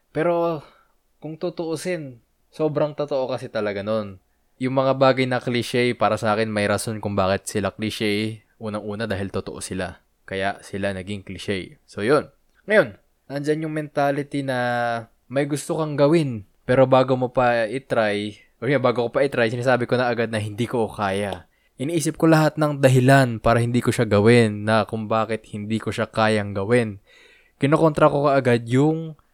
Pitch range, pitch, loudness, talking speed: 105-140 Hz, 120 Hz, -22 LUFS, 170 wpm